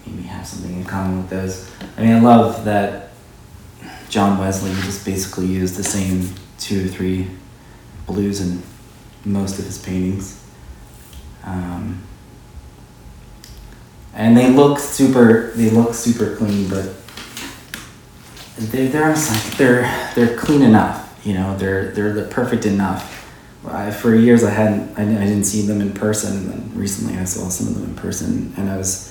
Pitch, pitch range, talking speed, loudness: 100 Hz, 95-115 Hz, 150 wpm, -17 LUFS